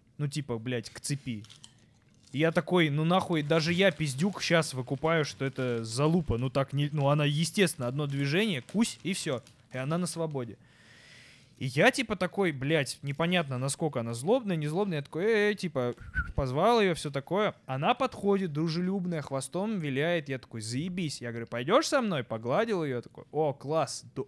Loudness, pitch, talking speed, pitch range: -30 LUFS, 150 Hz, 175 wpm, 130-180 Hz